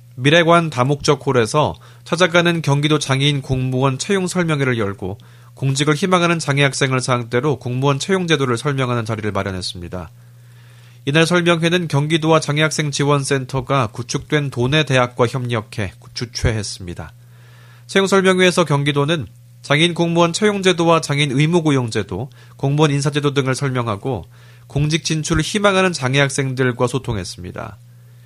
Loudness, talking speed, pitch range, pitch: -17 LUFS, 355 characters per minute, 120-155 Hz, 140 Hz